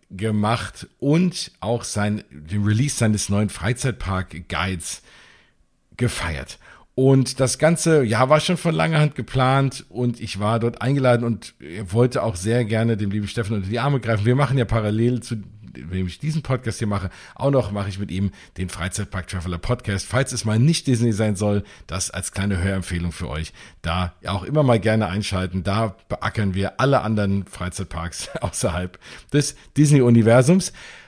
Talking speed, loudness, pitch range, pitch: 170 wpm, -21 LUFS, 95-125 Hz, 110 Hz